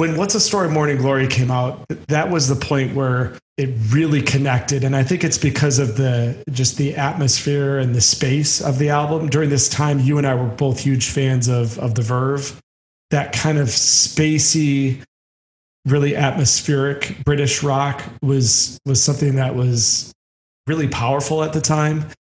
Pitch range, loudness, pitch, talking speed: 125-145 Hz, -17 LUFS, 140 Hz, 175 wpm